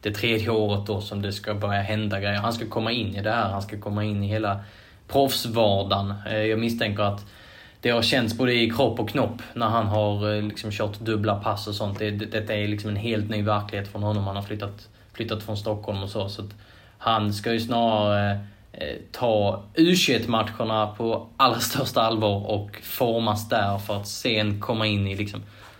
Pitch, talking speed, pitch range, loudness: 105 Hz, 200 wpm, 105-110 Hz, -25 LUFS